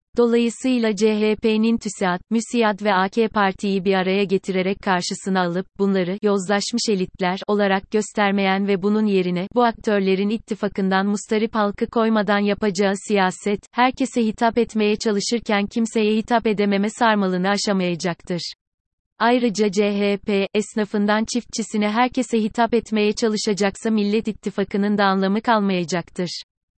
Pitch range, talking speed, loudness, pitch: 195-225 Hz, 110 wpm, -20 LUFS, 210 Hz